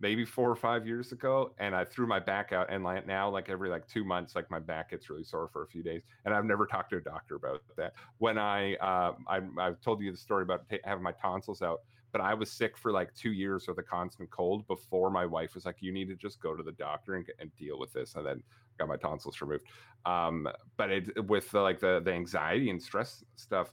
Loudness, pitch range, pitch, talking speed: -34 LUFS, 90-115 Hz, 95 Hz, 260 wpm